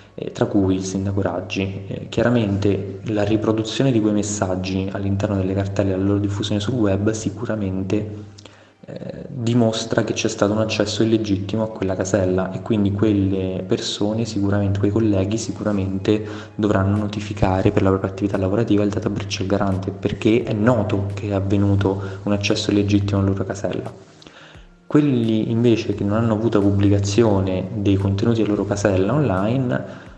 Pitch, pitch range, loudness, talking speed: 105 Hz, 95-110 Hz, -20 LUFS, 155 wpm